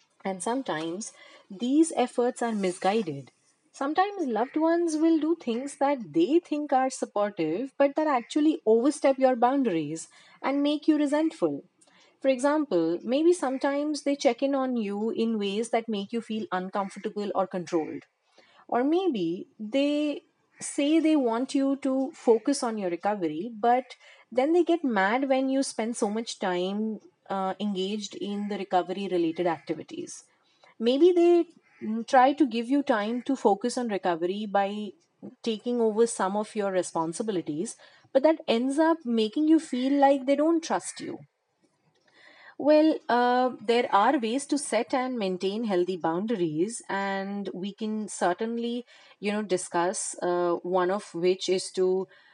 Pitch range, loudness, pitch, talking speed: 195-280 Hz, -27 LUFS, 235 Hz, 150 wpm